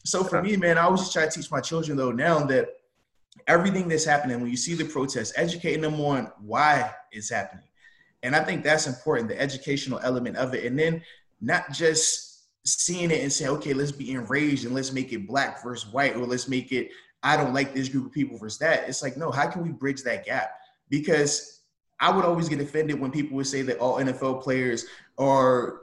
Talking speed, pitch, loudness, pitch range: 220 wpm, 145 Hz, -25 LUFS, 130-160 Hz